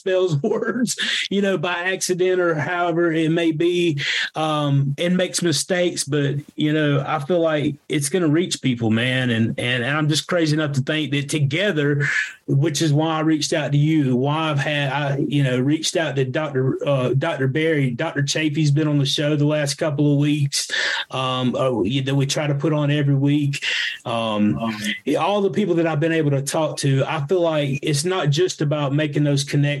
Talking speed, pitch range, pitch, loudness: 200 wpm, 140-165 Hz, 150 Hz, -20 LUFS